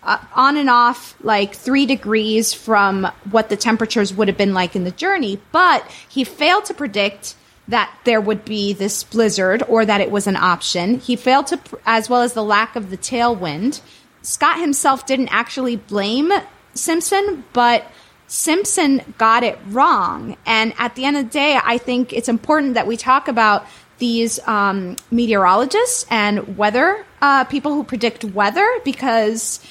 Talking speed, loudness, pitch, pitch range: 170 wpm, -17 LUFS, 235 Hz, 210-275 Hz